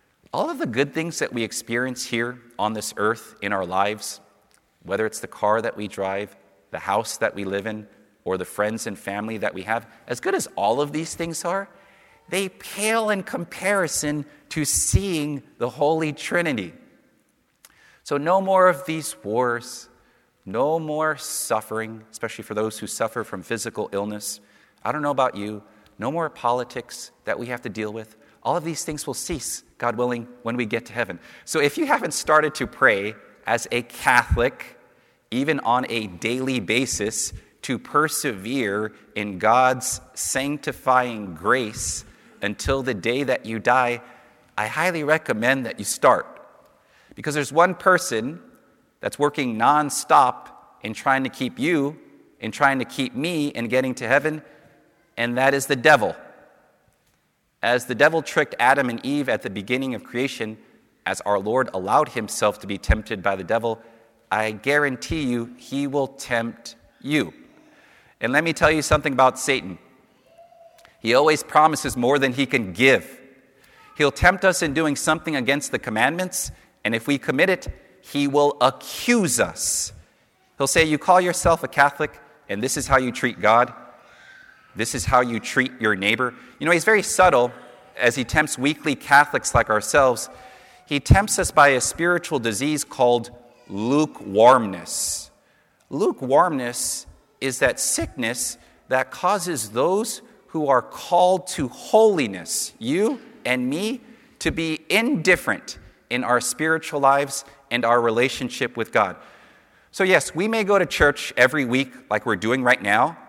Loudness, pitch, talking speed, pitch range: -22 LUFS, 130 Hz, 160 wpm, 115-155 Hz